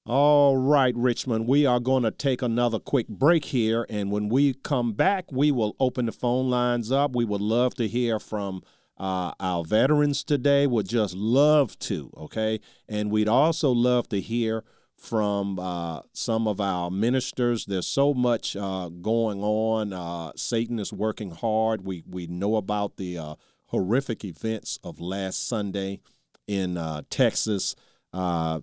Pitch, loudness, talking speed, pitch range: 110 Hz, -25 LUFS, 160 wpm, 100-125 Hz